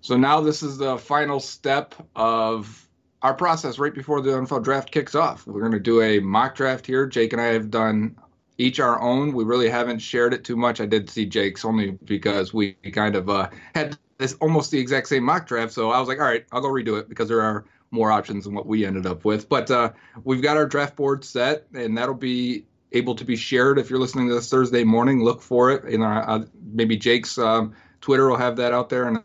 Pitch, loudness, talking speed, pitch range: 120 Hz, -22 LUFS, 240 wpm, 110-135 Hz